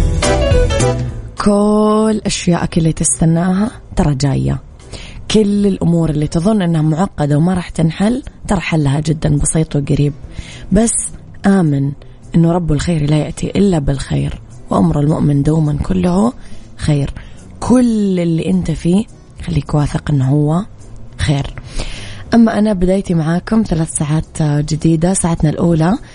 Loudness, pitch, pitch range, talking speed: -14 LUFS, 160 Hz, 145-185 Hz, 120 wpm